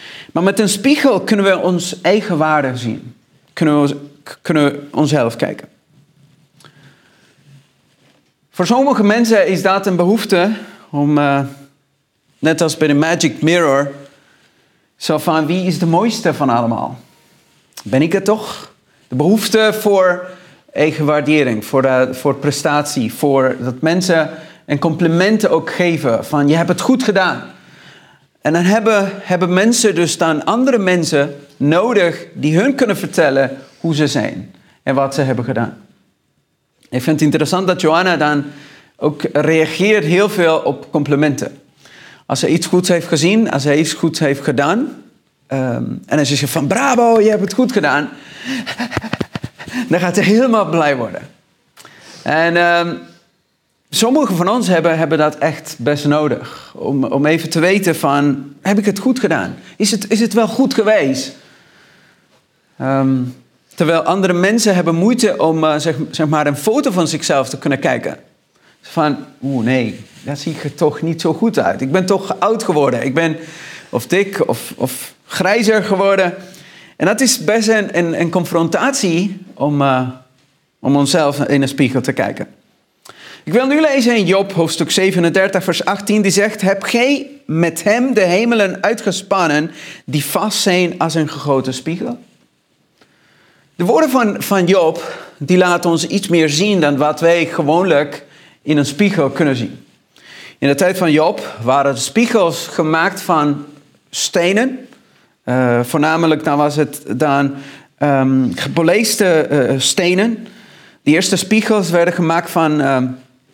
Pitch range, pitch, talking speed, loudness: 145-195 Hz, 165 Hz, 155 wpm, -15 LUFS